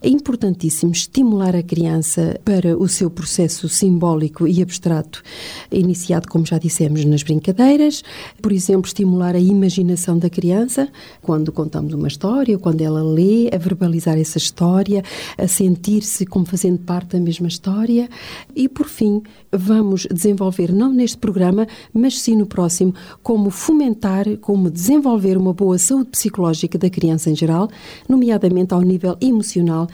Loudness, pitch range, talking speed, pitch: -17 LUFS, 170-210 Hz, 145 wpm, 185 Hz